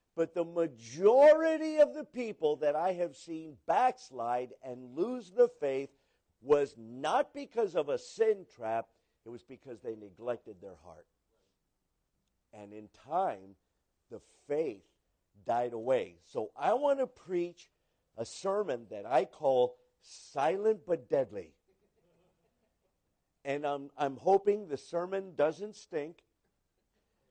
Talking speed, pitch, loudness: 125 wpm, 155 Hz, -32 LUFS